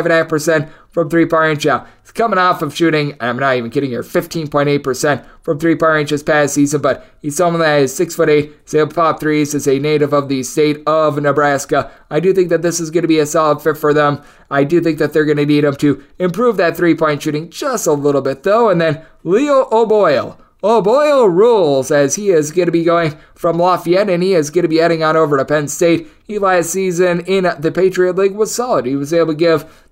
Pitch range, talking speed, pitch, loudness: 145-175 Hz, 240 wpm, 160 Hz, -14 LUFS